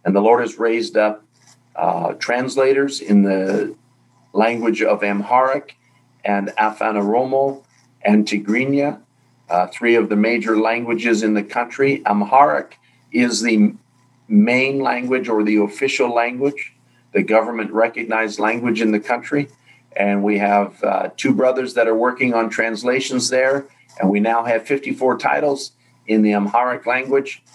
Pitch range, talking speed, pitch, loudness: 105-130 Hz, 140 wpm, 120 Hz, -18 LUFS